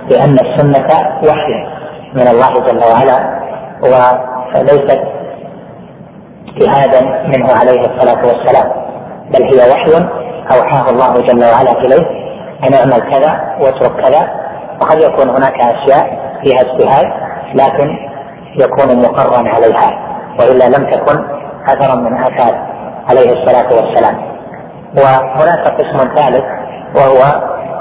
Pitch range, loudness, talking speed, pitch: 130-150 Hz, -9 LUFS, 105 wpm, 135 Hz